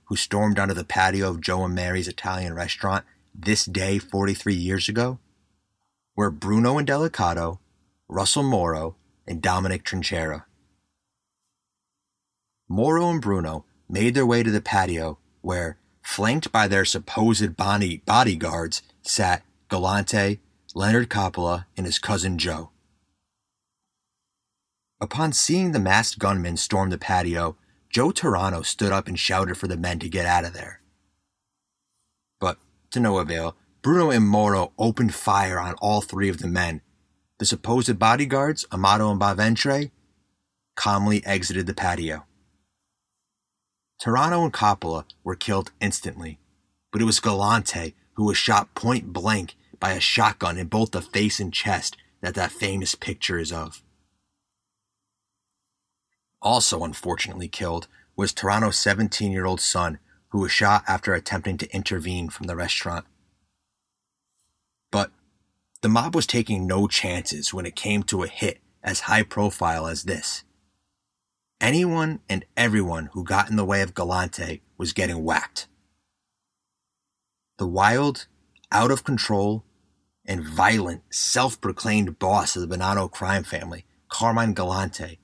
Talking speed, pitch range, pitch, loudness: 135 wpm, 90-105 Hz, 95 Hz, -23 LUFS